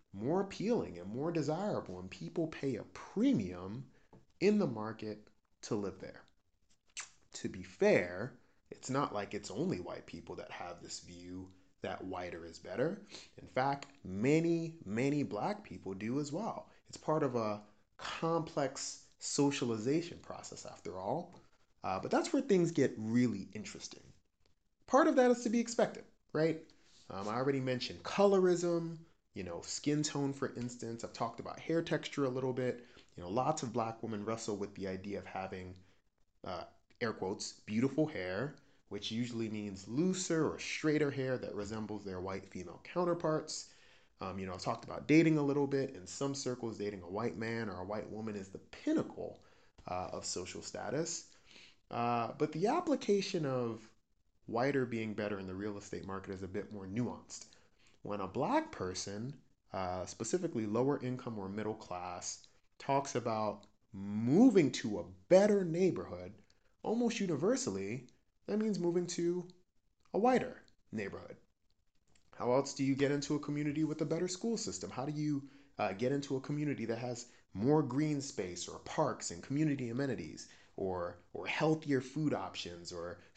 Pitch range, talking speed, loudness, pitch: 105-155 Hz, 165 wpm, -36 LUFS, 125 Hz